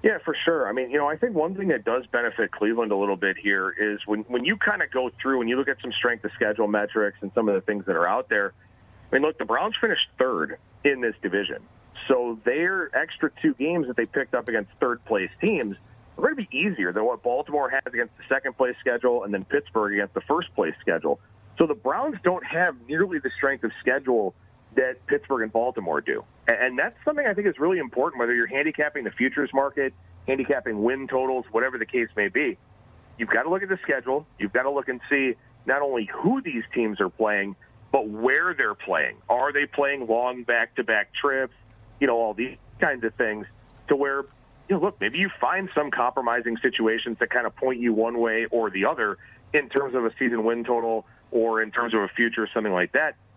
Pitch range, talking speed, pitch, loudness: 110-140 Hz, 230 wpm, 120 Hz, -25 LUFS